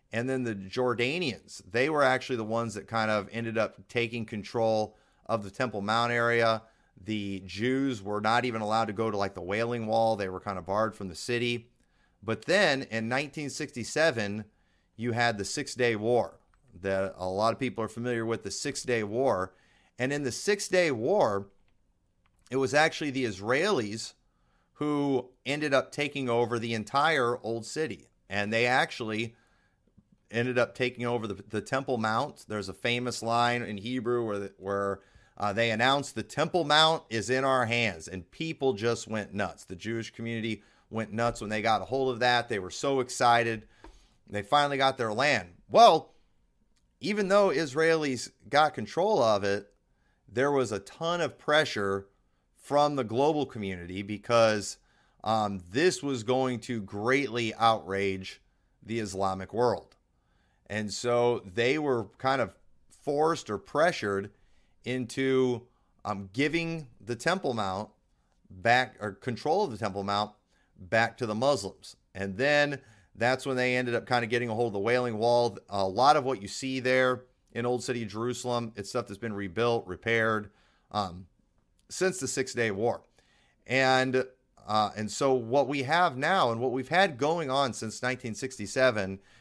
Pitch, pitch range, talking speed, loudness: 115 Hz, 105-130 Hz, 170 wpm, -29 LUFS